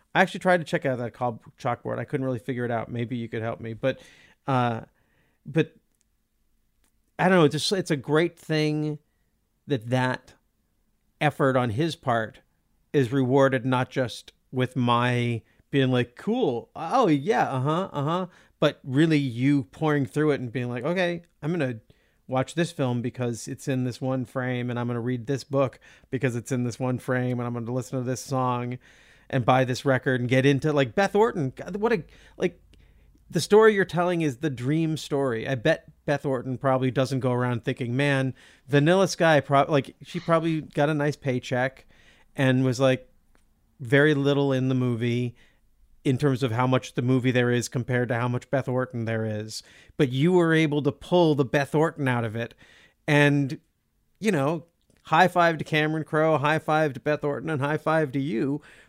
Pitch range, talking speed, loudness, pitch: 125-150 Hz, 195 wpm, -25 LUFS, 135 Hz